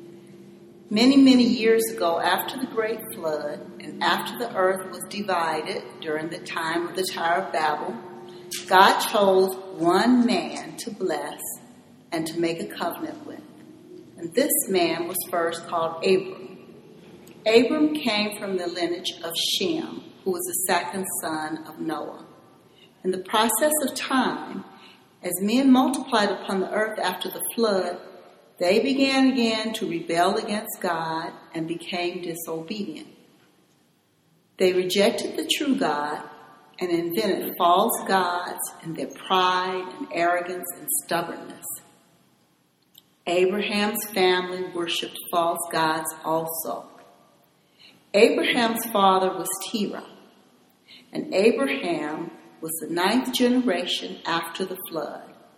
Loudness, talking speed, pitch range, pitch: -24 LUFS, 125 wpm, 170-220 Hz, 185 Hz